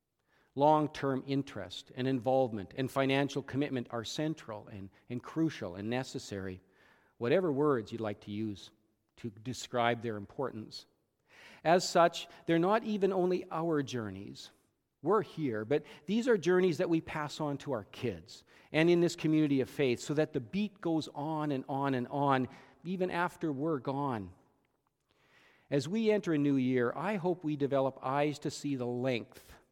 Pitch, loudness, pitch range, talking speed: 140 Hz, -33 LUFS, 125-160 Hz, 165 wpm